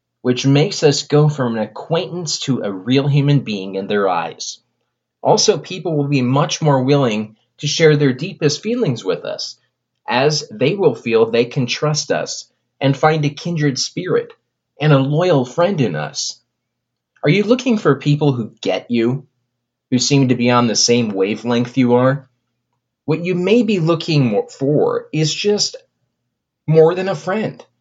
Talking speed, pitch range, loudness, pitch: 170 wpm, 125-170 Hz, -17 LUFS, 145 Hz